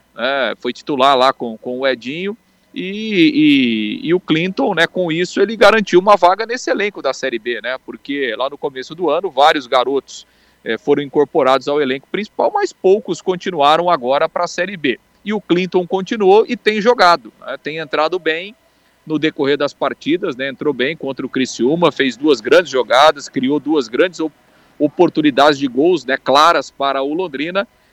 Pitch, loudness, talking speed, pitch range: 170 Hz, -16 LUFS, 180 wpm, 140-200 Hz